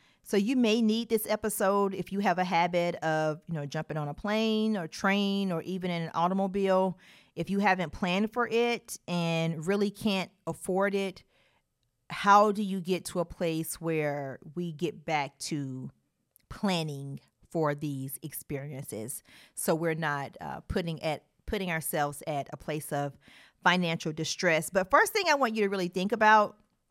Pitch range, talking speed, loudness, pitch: 155-200 Hz, 170 wpm, -29 LUFS, 175 Hz